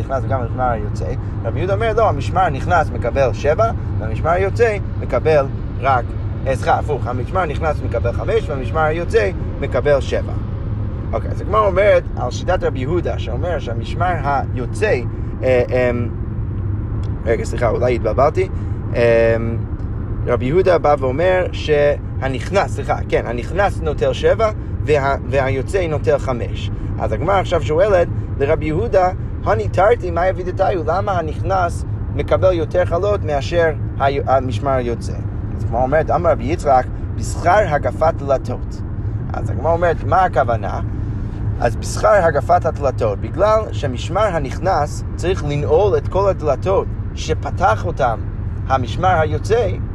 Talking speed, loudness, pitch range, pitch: 130 wpm, -18 LUFS, 100-120 Hz, 110 Hz